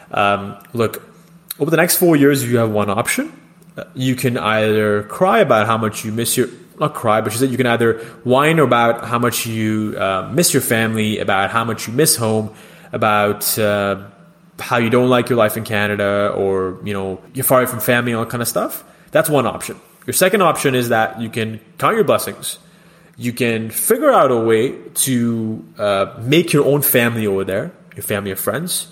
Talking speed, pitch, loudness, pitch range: 200 wpm, 115 Hz, -16 LUFS, 105-135 Hz